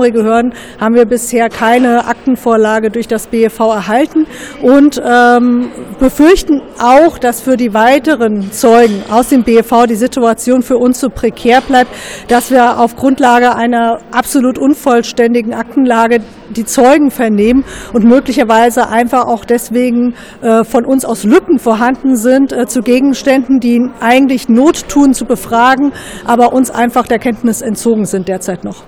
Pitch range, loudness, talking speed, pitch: 230-260 Hz, -10 LUFS, 145 wpm, 240 Hz